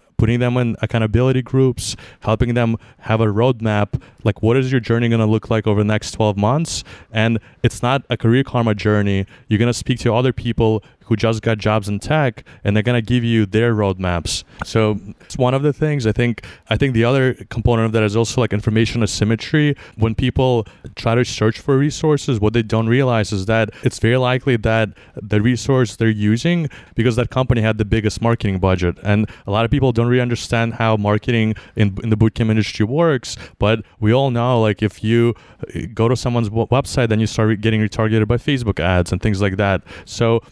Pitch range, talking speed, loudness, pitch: 105-125 Hz, 205 wpm, -18 LUFS, 115 Hz